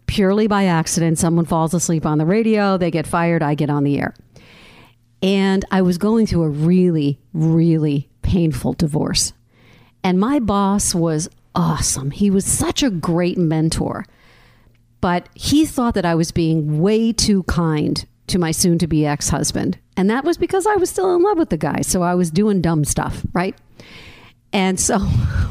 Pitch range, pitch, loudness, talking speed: 150-195 Hz, 170 Hz, -18 LUFS, 180 wpm